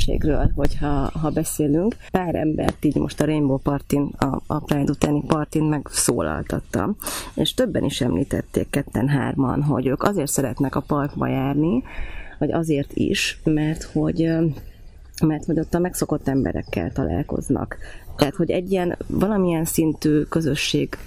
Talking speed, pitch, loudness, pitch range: 140 wpm, 150 Hz, -22 LUFS, 135-155 Hz